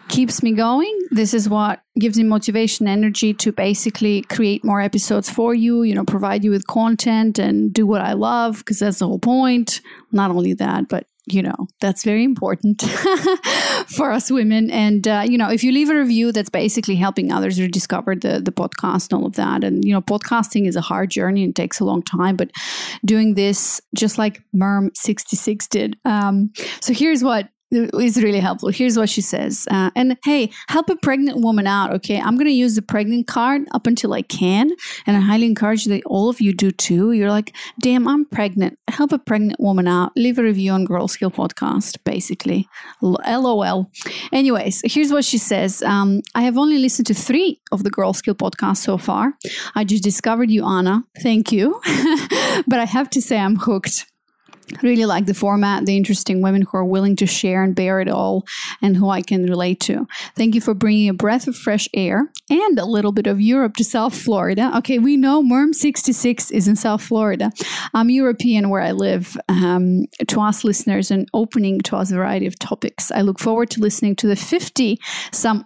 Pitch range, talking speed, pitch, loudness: 200-240 Hz, 200 wpm, 215 Hz, -18 LUFS